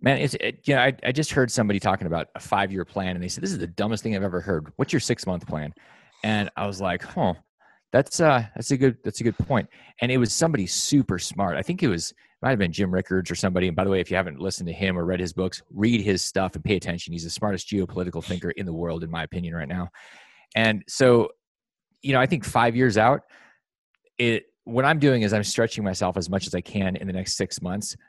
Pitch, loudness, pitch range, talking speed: 100 Hz, -24 LUFS, 90-115 Hz, 260 wpm